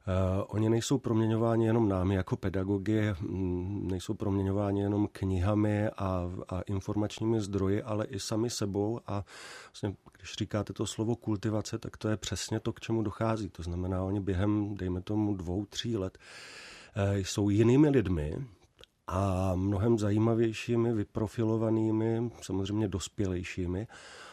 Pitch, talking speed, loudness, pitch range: 105 Hz, 130 wpm, -31 LUFS, 95-110 Hz